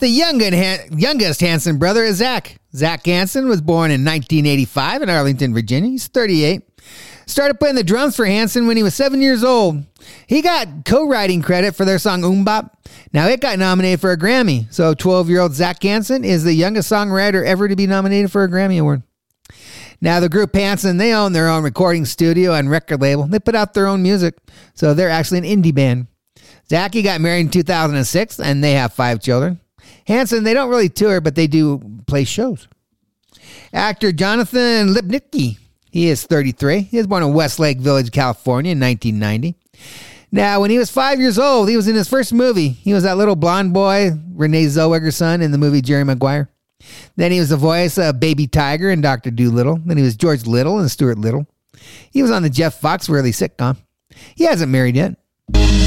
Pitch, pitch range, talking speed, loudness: 175 Hz, 145-205 Hz, 190 wpm, -15 LUFS